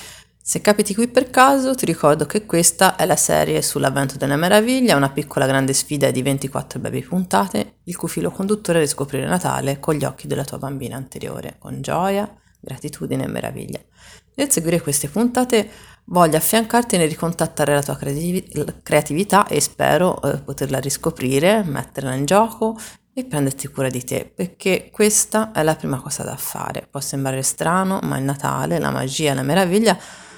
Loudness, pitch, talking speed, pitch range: -19 LUFS, 160 Hz, 165 wpm, 140-205 Hz